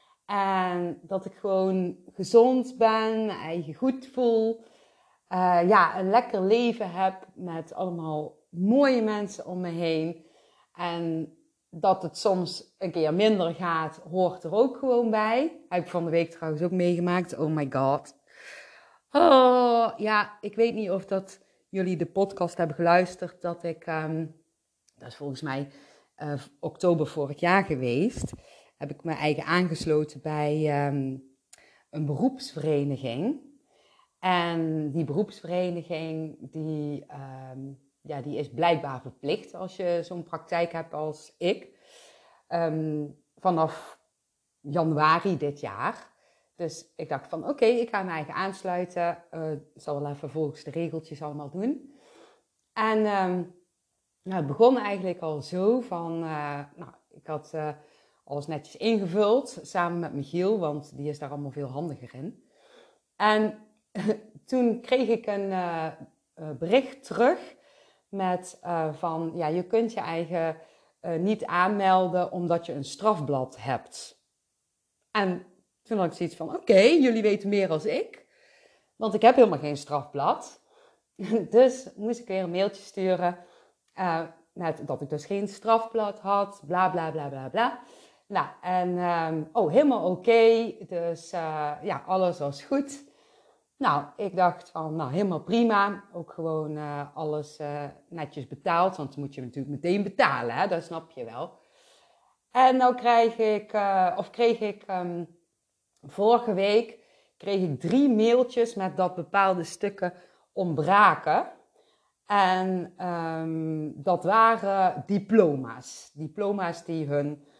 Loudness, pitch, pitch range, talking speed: -27 LUFS, 175 Hz, 155-205 Hz, 145 wpm